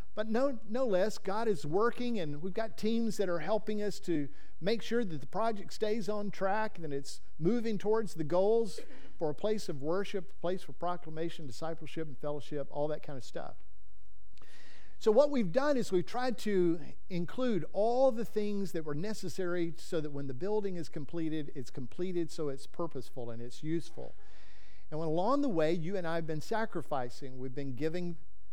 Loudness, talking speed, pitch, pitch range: -35 LUFS, 195 wpm, 175 Hz, 150-215 Hz